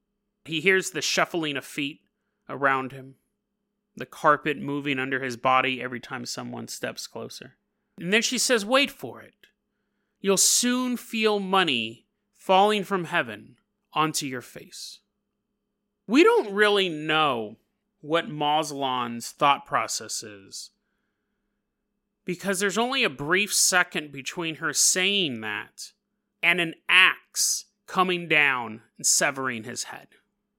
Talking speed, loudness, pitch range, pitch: 125 wpm, -24 LUFS, 140-210 Hz, 180 Hz